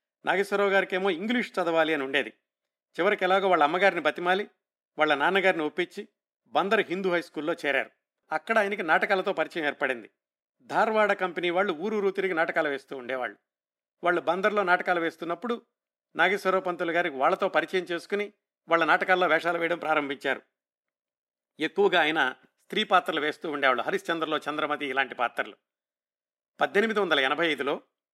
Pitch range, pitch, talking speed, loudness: 155-195 Hz, 175 Hz, 135 wpm, -26 LUFS